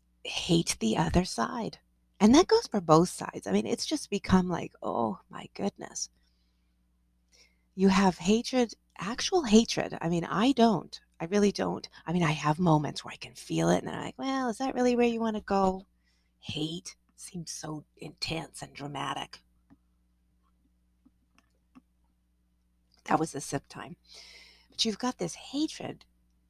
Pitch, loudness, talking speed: 165 Hz, -29 LUFS, 160 wpm